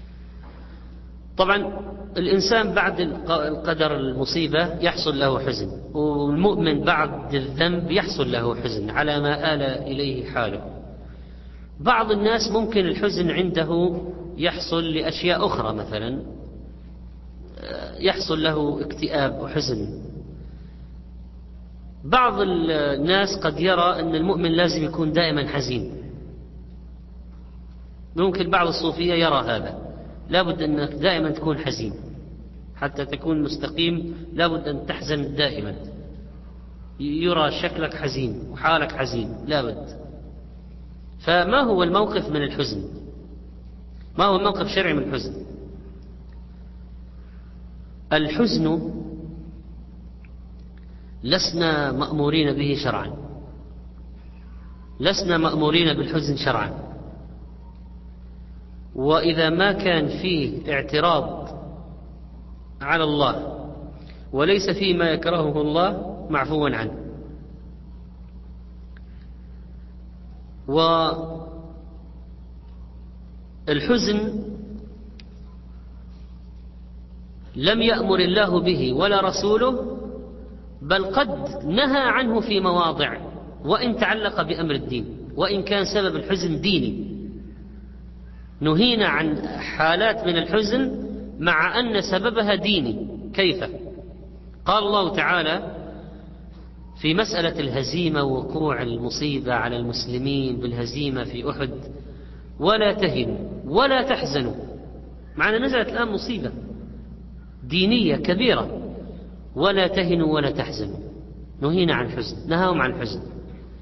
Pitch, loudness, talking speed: 145 Hz, -22 LUFS, 85 wpm